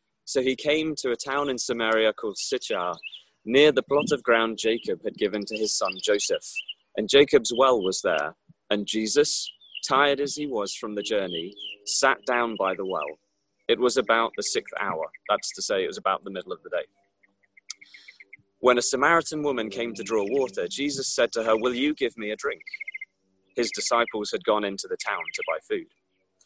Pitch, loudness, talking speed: 130 Hz, -25 LUFS, 195 wpm